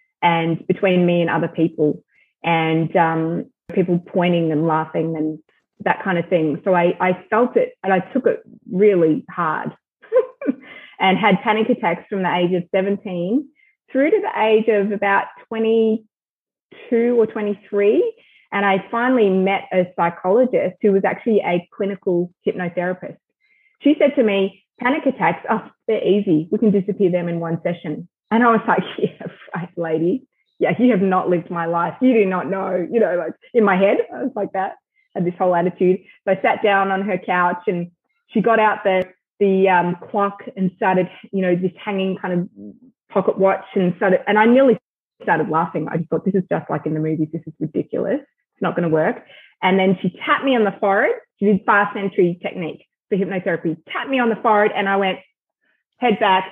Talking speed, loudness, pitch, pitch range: 195 wpm, -19 LUFS, 195 Hz, 175-225 Hz